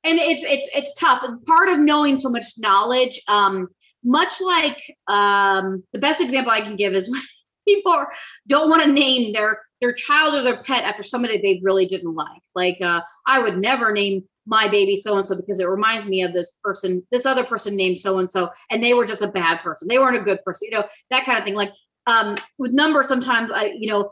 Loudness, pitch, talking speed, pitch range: -19 LUFS, 220 Hz, 225 wpm, 195-265 Hz